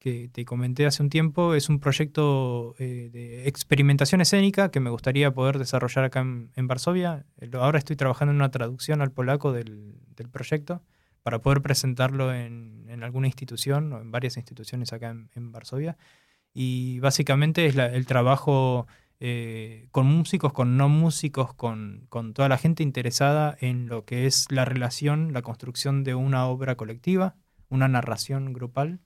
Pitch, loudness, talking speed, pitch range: 130 Hz, -25 LUFS, 165 wpm, 120-145 Hz